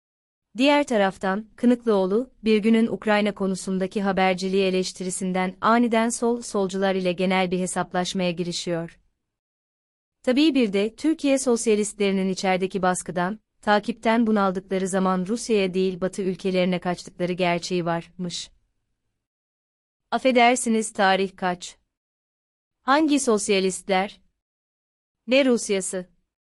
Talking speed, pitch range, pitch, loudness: 95 wpm, 185-225 Hz, 195 Hz, -23 LUFS